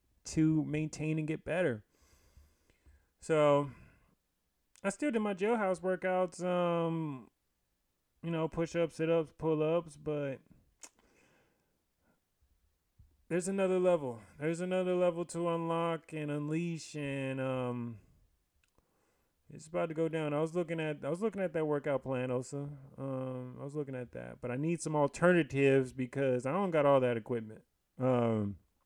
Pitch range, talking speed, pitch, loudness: 125-170 Hz, 145 wpm, 150 Hz, -34 LUFS